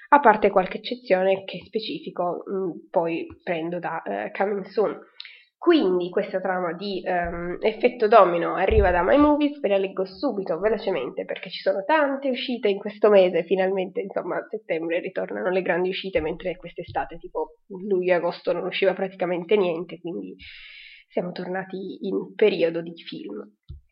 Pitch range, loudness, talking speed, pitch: 180-215 Hz, -24 LUFS, 155 wpm, 190 Hz